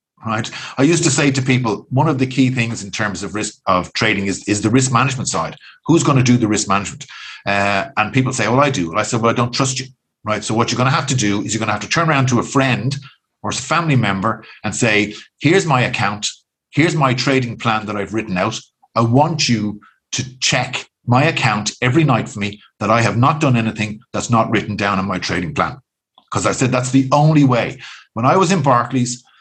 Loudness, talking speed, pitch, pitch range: -17 LUFS, 245 wpm, 120 Hz, 105-135 Hz